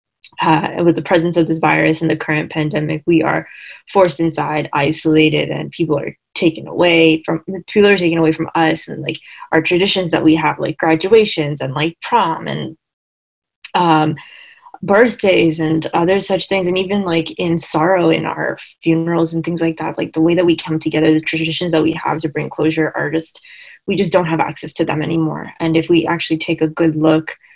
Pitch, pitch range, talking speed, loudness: 160 Hz, 155-175 Hz, 200 wpm, -16 LUFS